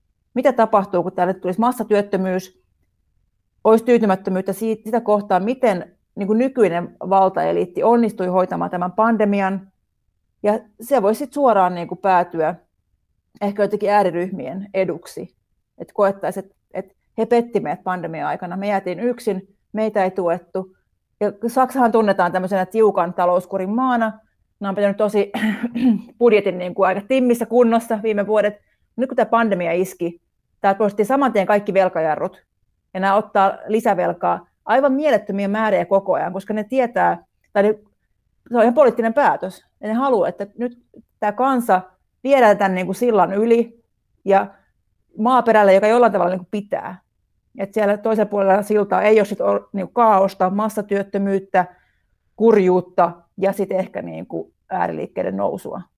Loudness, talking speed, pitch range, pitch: -19 LUFS, 145 wpm, 185-225 Hz, 200 Hz